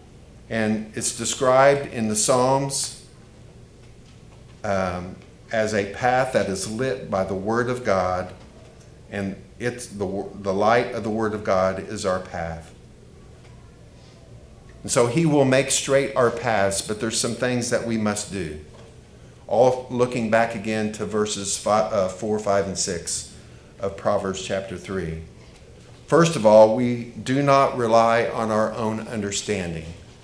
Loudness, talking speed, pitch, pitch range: -22 LUFS, 145 wpm, 110 Hz, 100-120 Hz